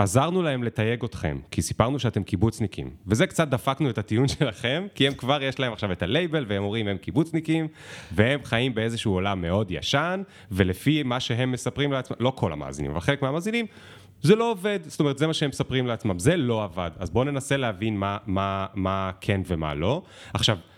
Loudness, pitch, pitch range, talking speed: -25 LUFS, 115 Hz, 100-140 Hz, 195 wpm